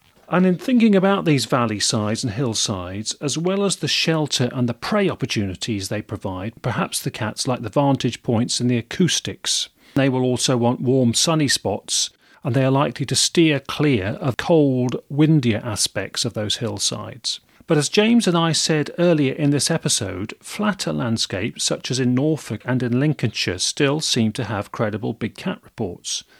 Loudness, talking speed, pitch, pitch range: -20 LUFS, 175 wpm, 130 Hz, 115-155 Hz